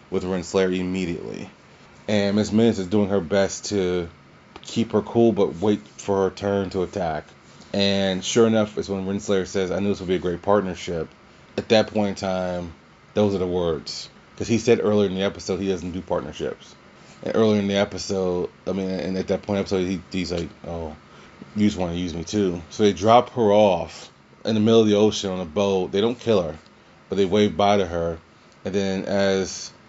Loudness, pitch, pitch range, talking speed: -23 LUFS, 95 Hz, 90-105 Hz, 215 wpm